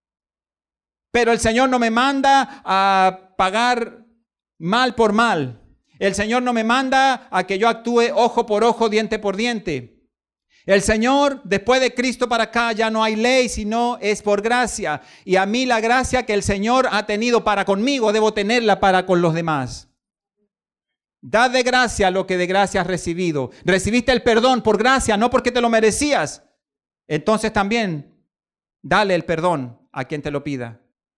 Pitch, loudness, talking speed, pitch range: 220 Hz, -18 LUFS, 170 wpm, 190-240 Hz